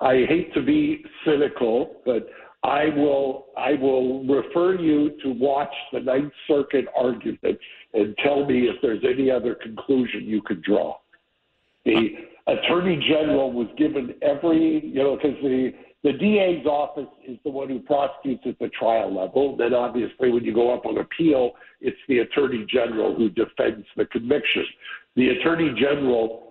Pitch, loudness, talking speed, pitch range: 140 Hz, -23 LUFS, 160 wpm, 125-150 Hz